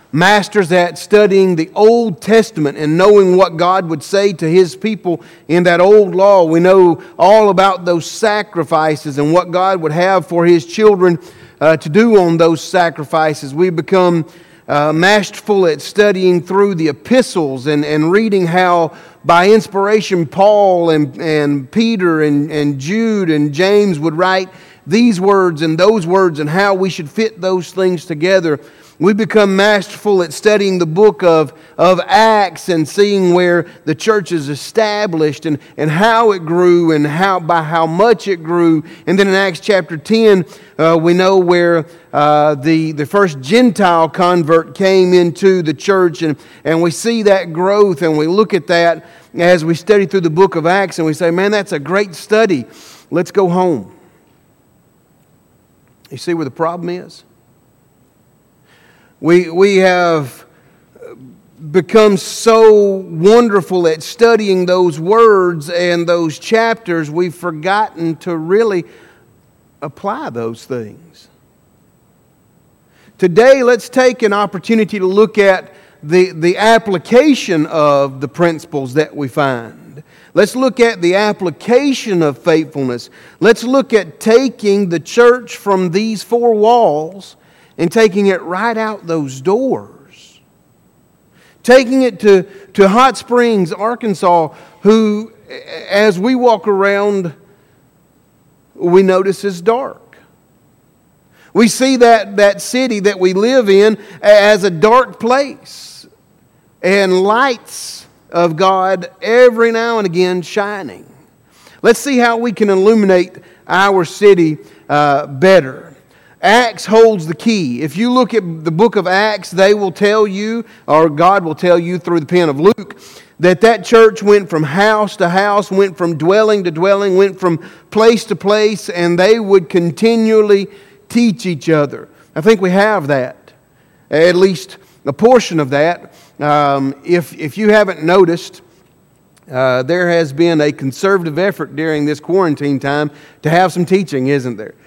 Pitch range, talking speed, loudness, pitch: 165-210 Hz, 150 wpm, -12 LUFS, 185 Hz